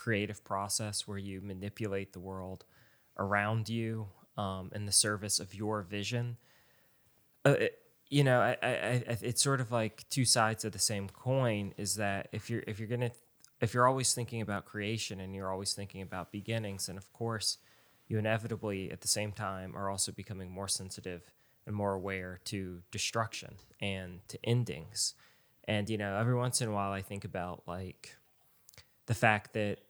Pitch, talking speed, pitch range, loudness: 105 Hz, 180 wpm, 100-115 Hz, -34 LUFS